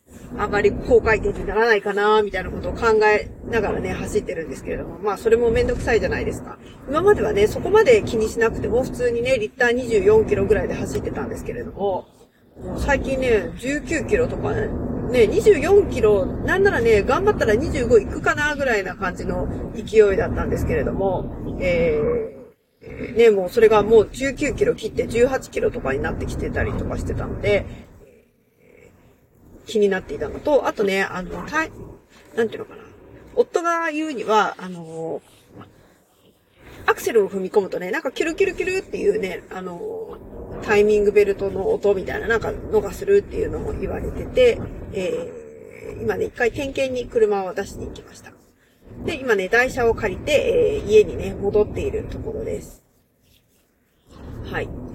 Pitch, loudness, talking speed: 330 Hz, -20 LUFS, 340 characters per minute